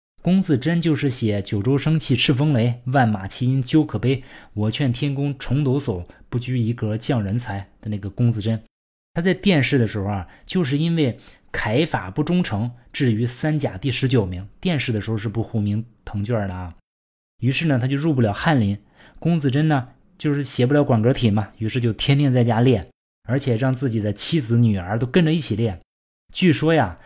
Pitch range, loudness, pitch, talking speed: 110-145 Hz, -21 LUFS, 125 Hz, 285 characters per minute